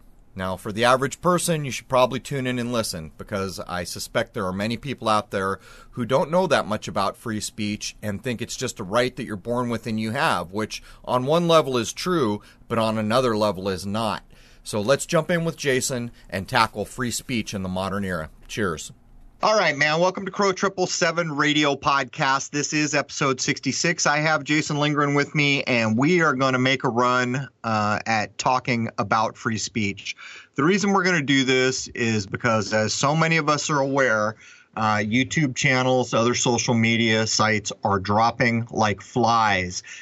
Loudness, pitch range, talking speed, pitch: -22 LUFS, 110-145 Hz, 195 wpm, 125 Hz